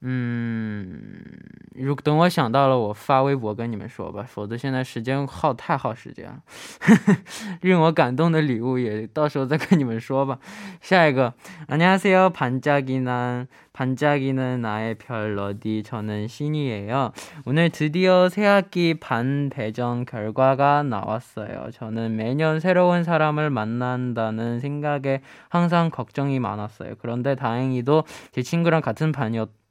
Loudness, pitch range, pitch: -22 LUFS, 120-160 Hz, 135 Hz